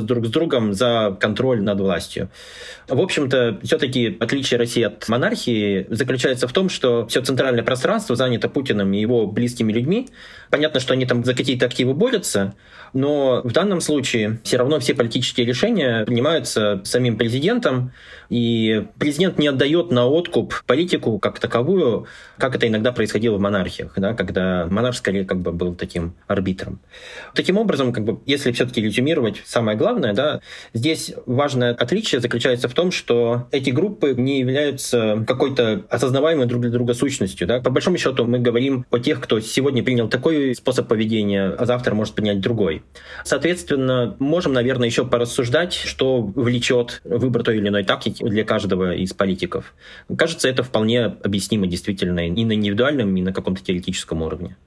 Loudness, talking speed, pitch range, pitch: -20 LUFS, 160 wpm, 105-130 Hz, 120 Hz